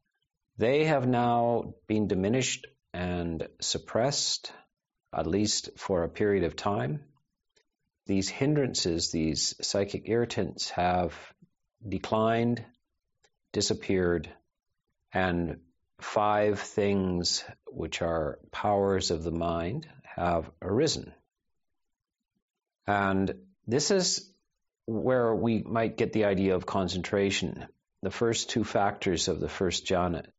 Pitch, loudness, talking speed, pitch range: 100 Hz, -29 LUFS, 105 wpm, 90-115 Hz